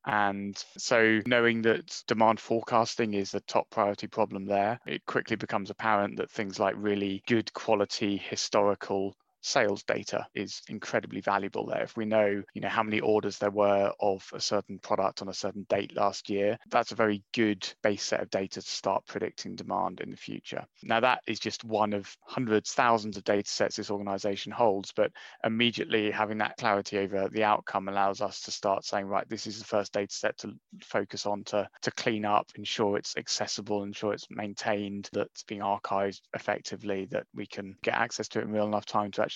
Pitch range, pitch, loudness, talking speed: 100-110 Hz, 105 Hz, -30 LUFS, 195 wpm